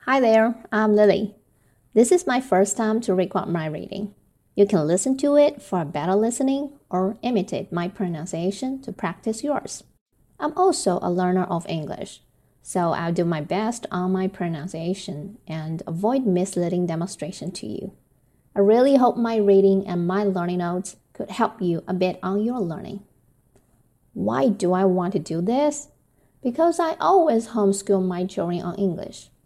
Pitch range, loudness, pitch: 180-230 Hz, -22 LUFS, 195 Hz